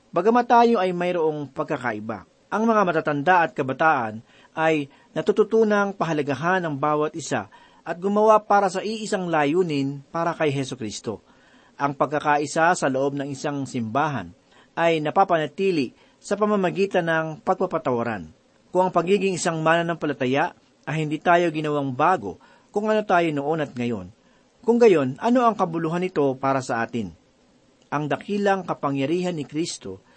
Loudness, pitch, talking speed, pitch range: -23 LUFS, 160 Hz, 140 wpm, 140-190 Hz